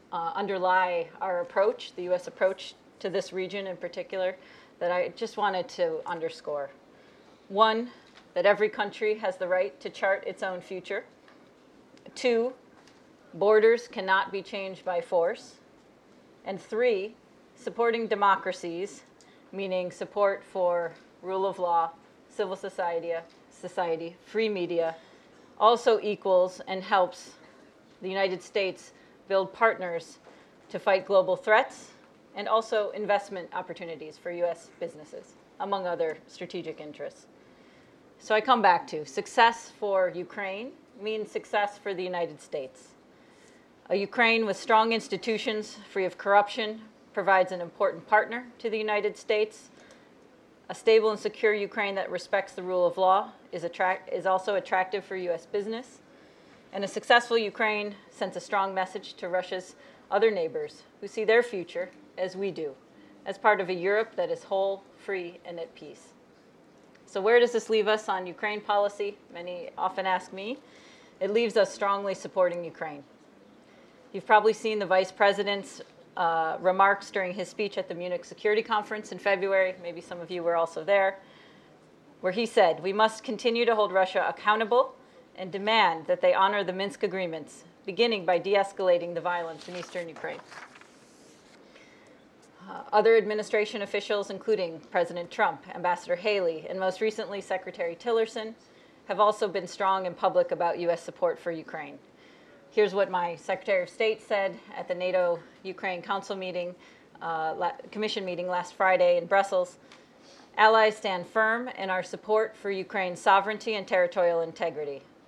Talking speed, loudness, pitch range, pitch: 150 wpm, -28 LUFS, 180-215 Hz, 195 Hz